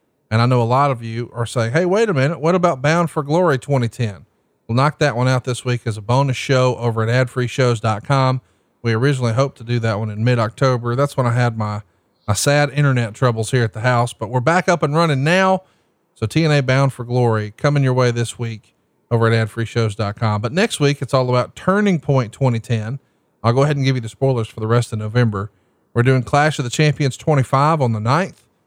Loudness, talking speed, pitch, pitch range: -18 LUFS, 225 wpm, 125 Hz, 115-140 Hz